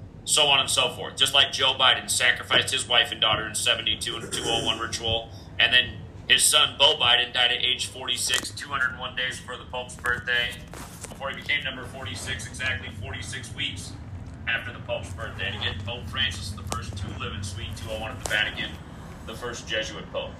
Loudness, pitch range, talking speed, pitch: -23 LUFS, 95-120 Hz, 195 wpm, 110 Hz